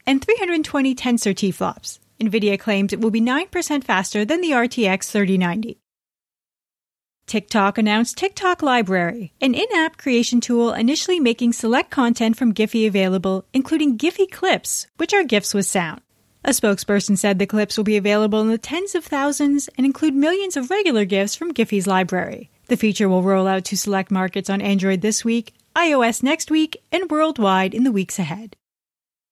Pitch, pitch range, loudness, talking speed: 230 Hz, 200-290 Hz, -19 LUFS, 170 wpm